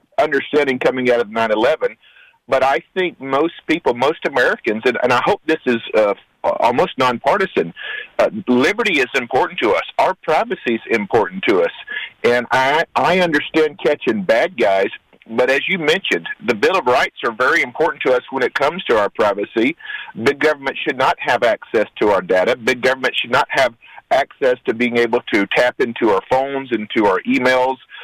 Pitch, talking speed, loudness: 155 Hz, 185 wpm, -17 LUFS